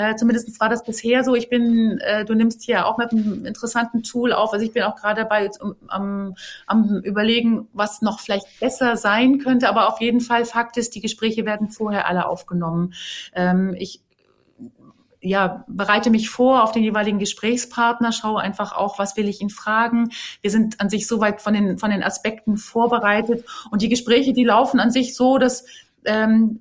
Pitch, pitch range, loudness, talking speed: 220 Hz, 205-235 Hz, -20 LUFS, 190 wpm